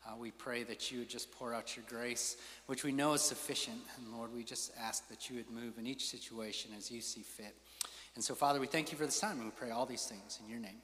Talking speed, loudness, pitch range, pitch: 275 wpm, -40 LUFS, 115-135 Hz, 120 Hz